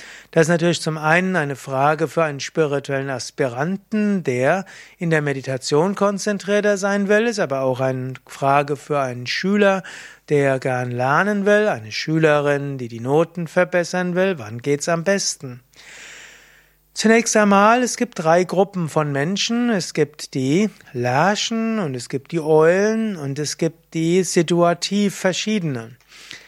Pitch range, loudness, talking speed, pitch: 140-195 Hz, -19 LUFS, 145 wpm, 165 Hz